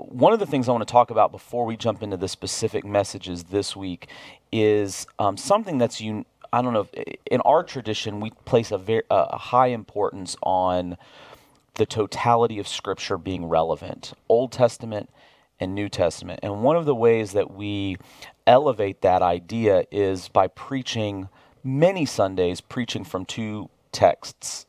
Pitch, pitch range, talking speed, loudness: 105 Hz, 95-120 Hz, 165 wpm, -23 LUFS